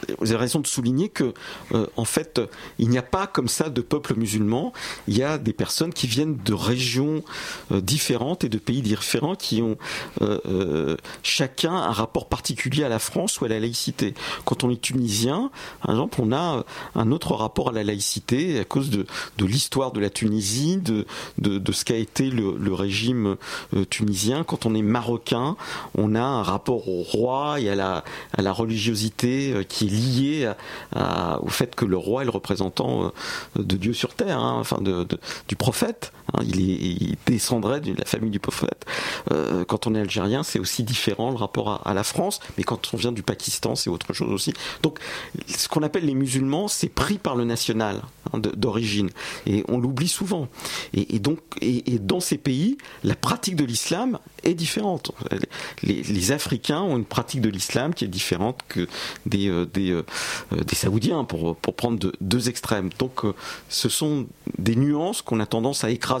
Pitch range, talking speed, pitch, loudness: 105-135 Hz, 200 wpm, 120 Hz, -24 LUFS